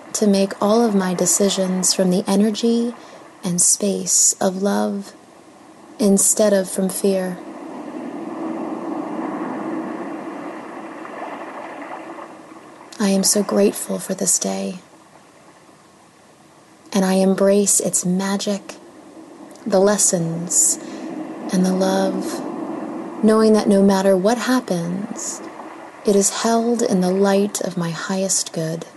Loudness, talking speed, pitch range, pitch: -18 LUFS, 105 wpm, 190-310 Hz, 210 Hz